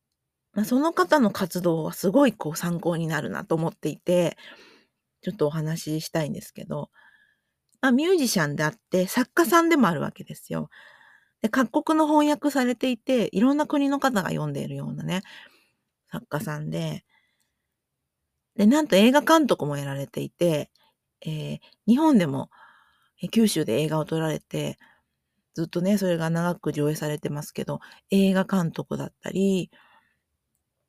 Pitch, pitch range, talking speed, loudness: 185 Hz, 155-260 Hz, 300 characters per minute, -24 LUFS